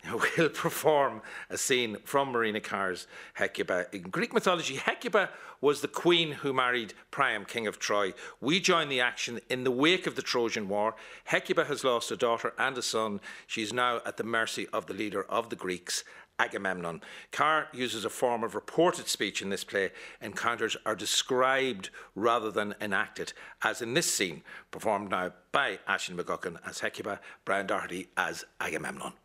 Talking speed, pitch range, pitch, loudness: 170 wpm, 110-140 Hz, 125 Hz, -30 LUFS